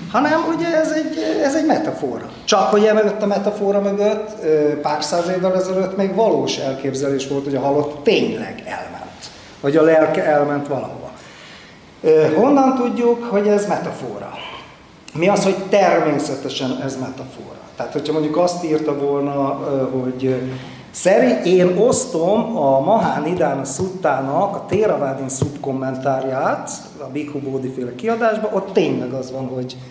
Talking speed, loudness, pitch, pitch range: 140 wpm, -18 LUFS, 150 Hz, 135-200 Hz